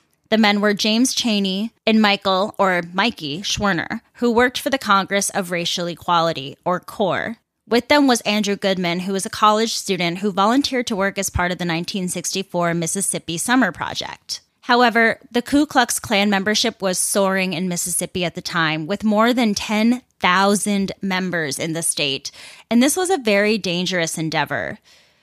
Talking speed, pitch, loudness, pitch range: 165 wpm, 195 Hz, -19 LUFS, 175-225 Hz